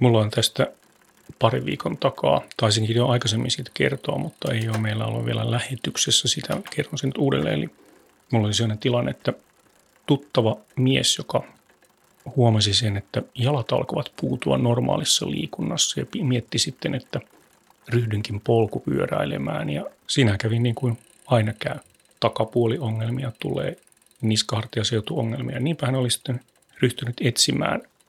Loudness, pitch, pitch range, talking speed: -23 LUFS, 120 Hz, 110-130 Hz, 135 wpm